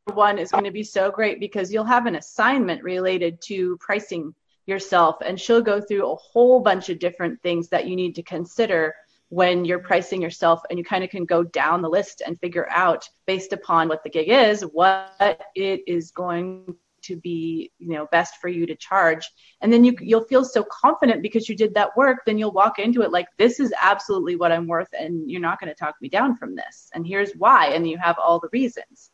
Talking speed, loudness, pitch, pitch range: 225 wpm, -21 LUFS, 185 Hz, 170-215 Hz